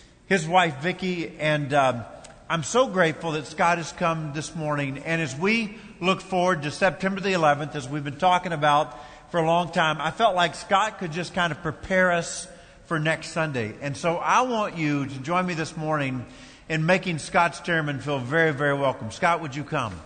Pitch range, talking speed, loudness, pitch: 150-180 Hz, 200 wpm, -24 LUFS, 165 Hz